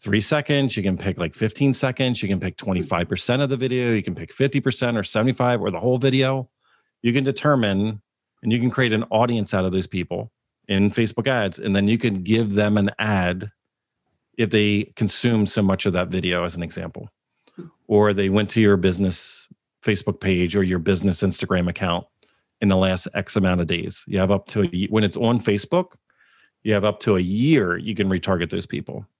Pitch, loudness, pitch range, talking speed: 105 Hz, -21 LUFS, 95-120 Hz, 210 wpm